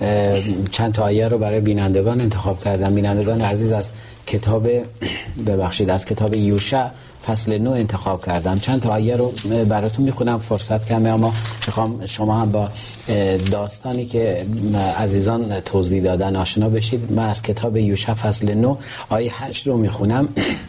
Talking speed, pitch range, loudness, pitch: 145 wpm, 100-115 Hz, -19 LUFS, 110 Hz